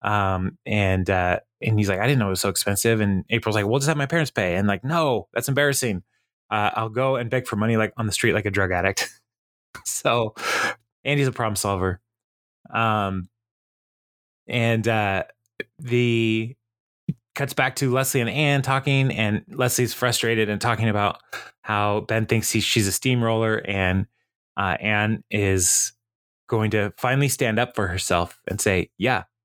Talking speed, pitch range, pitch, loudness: 175 wpm, 100-125 Hz, 110 Hz, -22 LUFS